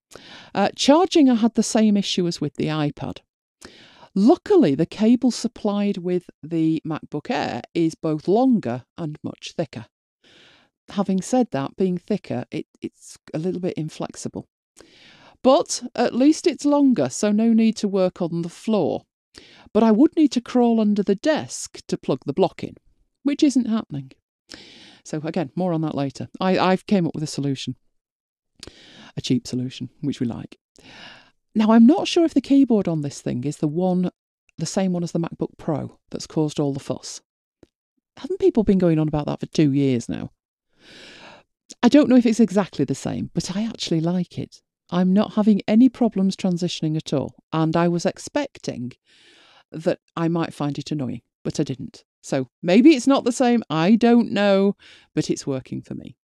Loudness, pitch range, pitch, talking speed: -21 LUFS, 155-235 Hz, 185 Hz, 180 wpm